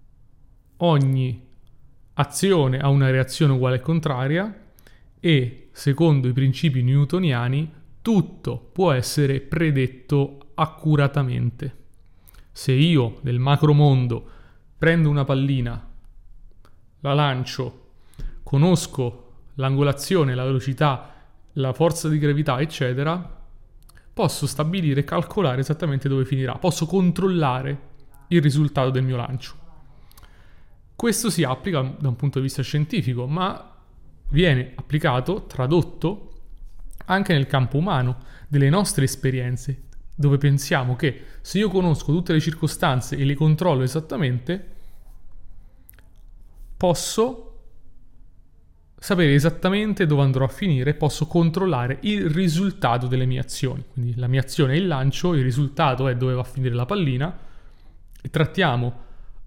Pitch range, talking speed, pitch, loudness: 125-160 Hz, 115 wpm, 140 Hz, -22 LUFS